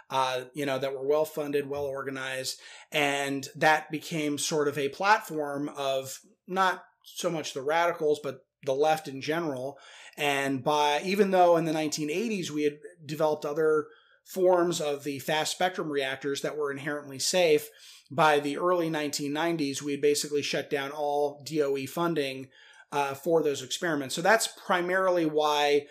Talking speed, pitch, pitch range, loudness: 155 wpm, 150 Hz, 140-165 Hz, -28 LUFS